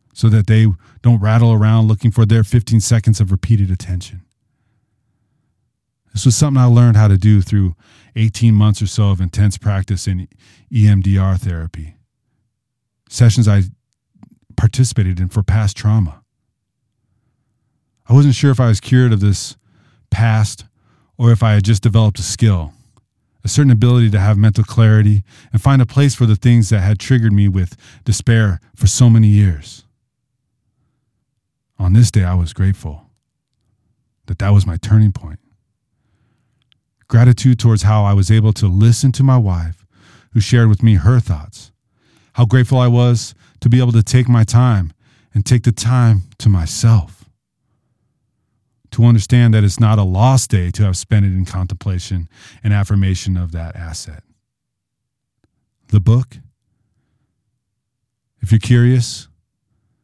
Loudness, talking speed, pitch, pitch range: -14 LUFS, 150 wpm, 110 Hz, 100-120 Hz